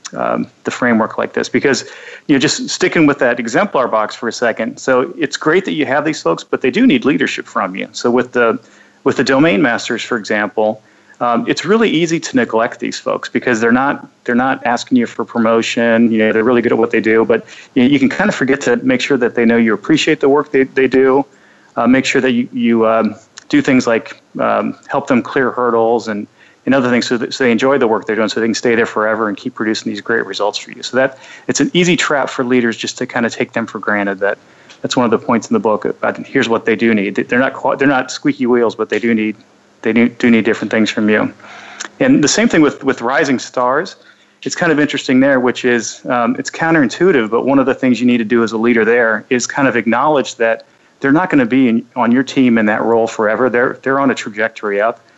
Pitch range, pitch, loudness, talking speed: 115-135 Hz, 125 Hz, -14 LUFS, 250 wpm